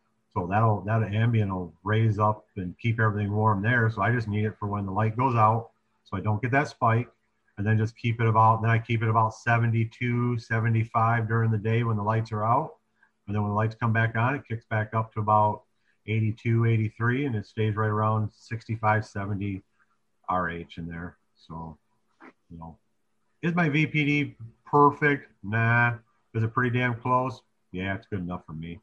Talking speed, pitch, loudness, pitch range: 200 wpm, 110 Hz, -26 LUFS, 105-115 Hz